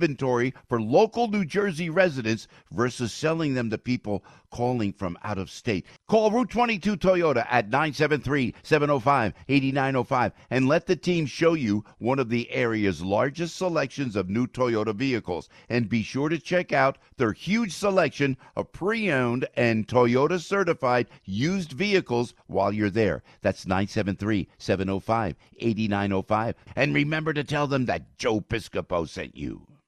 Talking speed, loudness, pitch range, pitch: 140 wpm, -25 LUFS, 110-160 Hz, 130 Hz